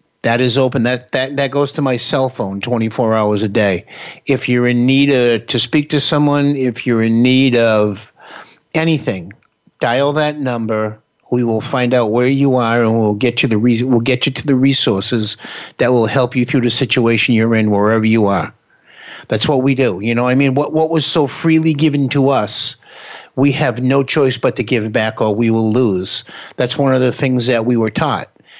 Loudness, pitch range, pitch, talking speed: -14 LUFS, 115-135 Hz, 125 Hz, 215 wpm